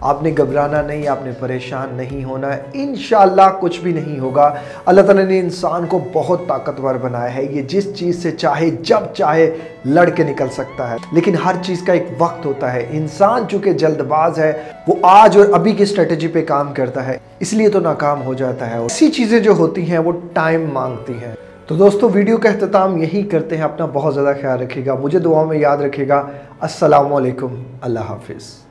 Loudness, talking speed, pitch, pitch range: -15 LUFS, 205 wpm, 155 Hz, 135-180 Hz